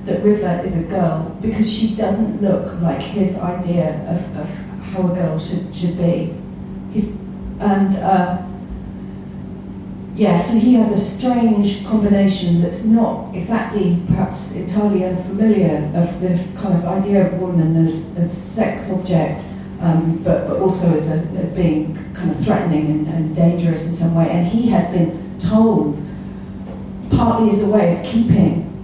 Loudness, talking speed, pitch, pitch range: -17 LUFS, 155 wpm, 185 Hz, 170-200 Hz